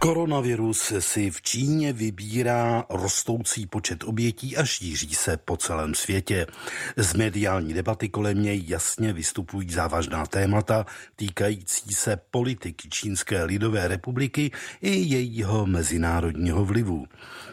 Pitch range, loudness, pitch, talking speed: 90-115 Hz, -25 LUFS, 105 Hz, 115 wpm